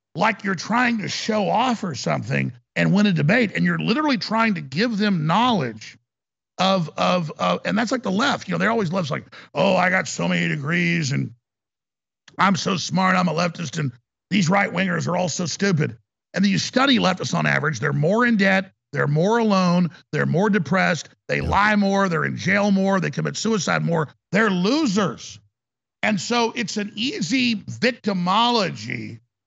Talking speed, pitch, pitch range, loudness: 185 wpm, 185 Hz, 155-210 Hz, -21 LUFS